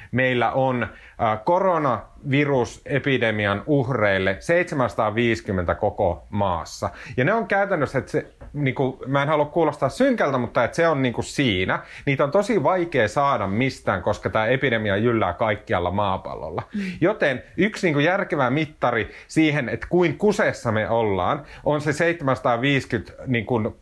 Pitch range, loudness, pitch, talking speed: 110-150 Hz, -22 LUFS, 130 Hz, 140 wpm